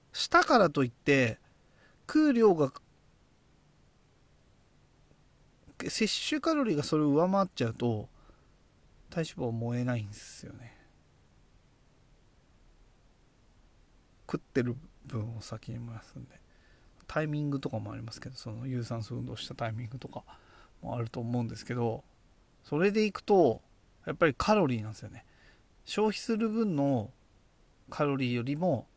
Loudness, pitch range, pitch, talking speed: -30 LUFS, 115-155 Hz, 125 Hz, 260 characters per minute